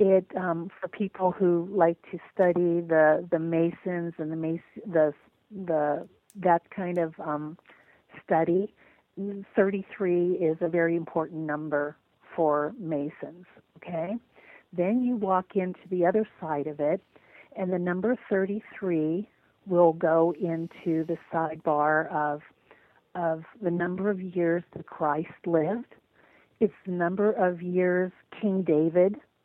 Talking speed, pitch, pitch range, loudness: 130 wpm, 175 Hz, 160-190 Hz, -28 LUFS